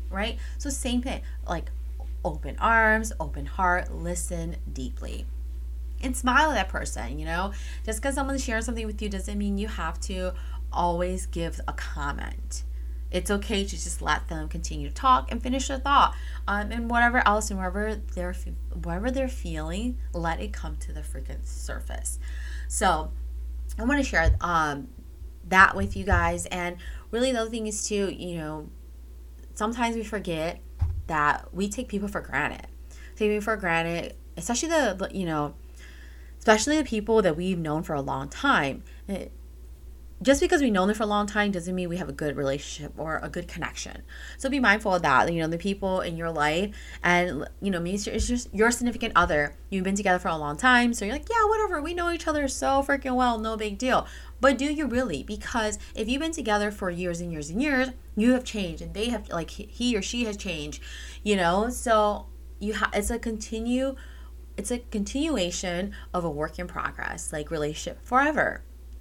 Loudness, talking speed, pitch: -27 LUFS, 190 wpm, 180 Hz